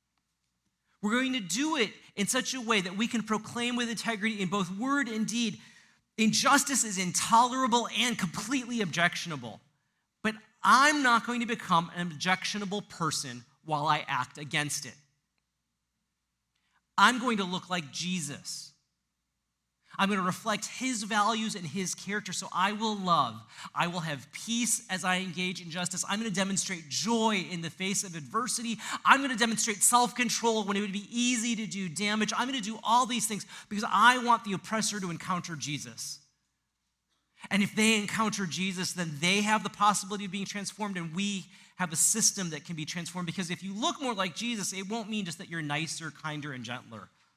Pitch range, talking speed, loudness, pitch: 170-225 Hz, 185 wpm, -29 LUFS, 195 Hz